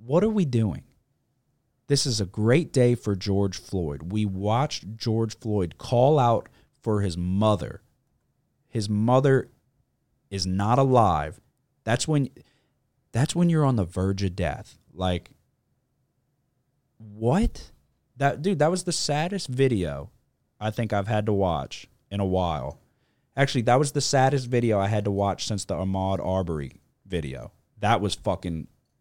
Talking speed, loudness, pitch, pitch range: 150 wpm, -25 LUFS, 115 Hz, 100-135 Hz